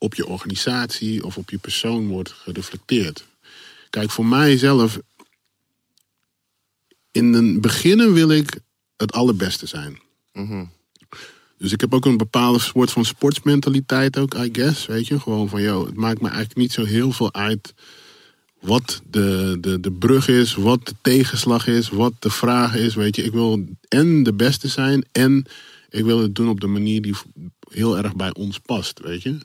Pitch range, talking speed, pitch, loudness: 105-130 Hz, 175 wpm, 115 Hz, -19 LUFS